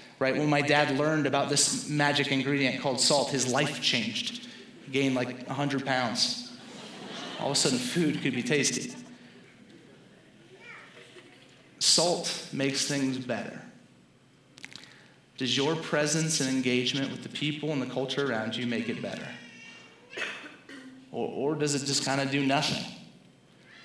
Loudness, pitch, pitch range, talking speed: -28 LUFS, 140 Hz, 130-155 Hz, 140 wpm